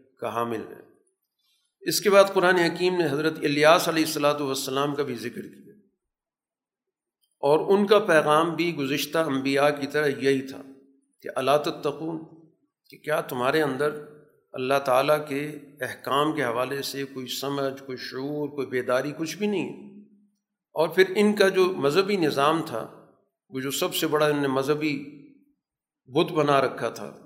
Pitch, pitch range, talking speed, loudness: 150 Hz, 135-170 Hz, 155 wpm, -24 LUFS